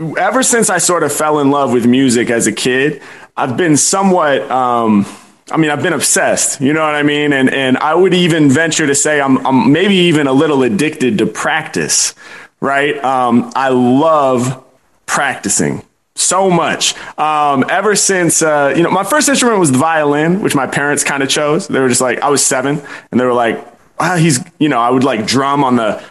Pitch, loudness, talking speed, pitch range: 145 Hz, -12 LUFS, 205 wpm, 130-160 Hz